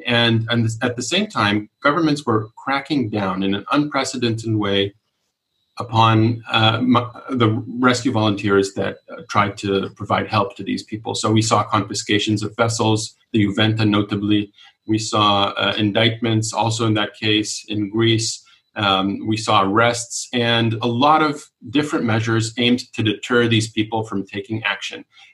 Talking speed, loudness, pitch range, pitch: 150 wpm, -19 LUFS, 105-120 Hz, 110 Hz